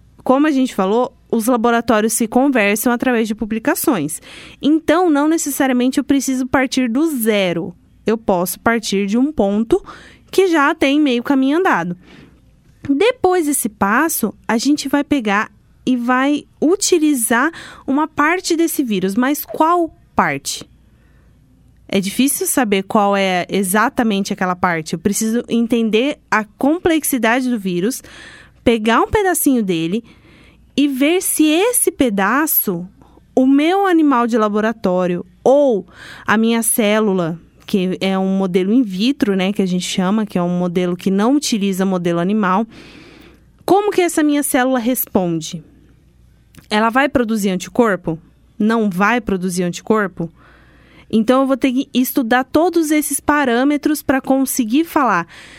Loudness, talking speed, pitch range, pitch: -16 LUFS, 135 wpm, 200-285 Hz, 245 Hz